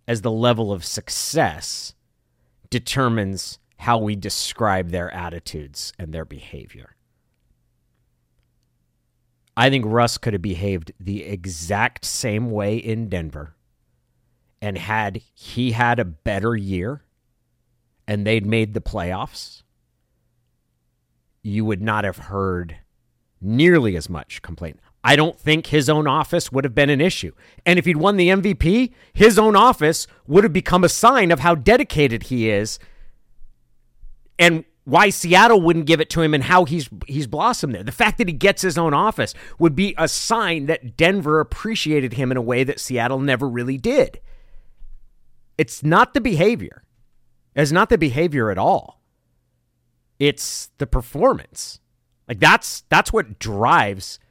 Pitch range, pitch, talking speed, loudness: 95-155 Hz, 120 Hz, 145 wpm, -18 LUFS